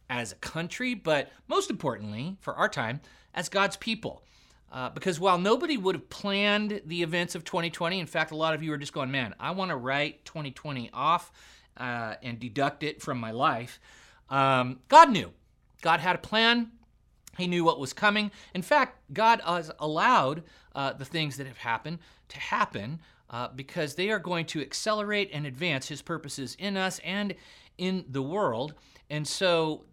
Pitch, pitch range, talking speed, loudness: 165 Hz, 140-190 Hz, 180 wpm, -28 LUFS